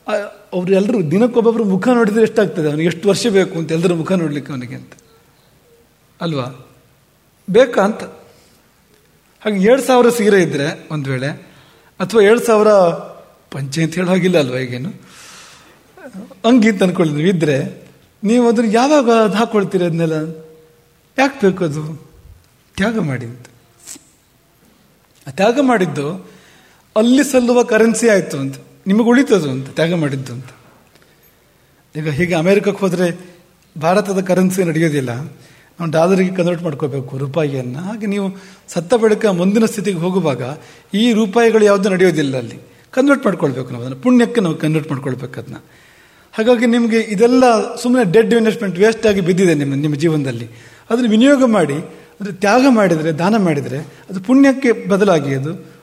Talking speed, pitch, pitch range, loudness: 125 wpm, 185 Hz, 155-220 Hz, -15 LUFS